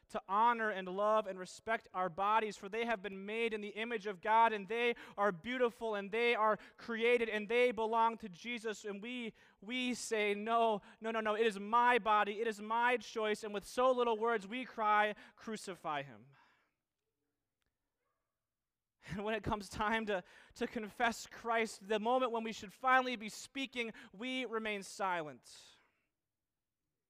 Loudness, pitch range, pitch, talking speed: -36 LUFS, 210-235 Hz, 225 Hz, 170 wpm